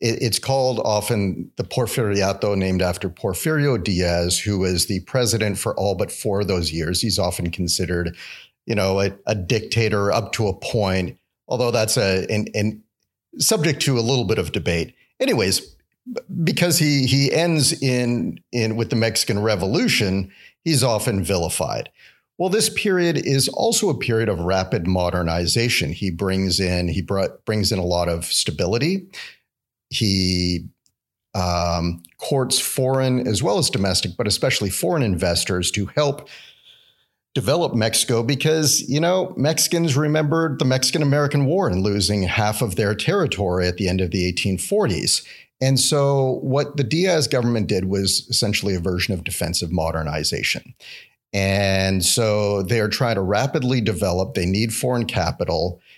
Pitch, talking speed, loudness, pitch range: 105 Hz, 150 wpm, -20 LUFS, 95-130 Hz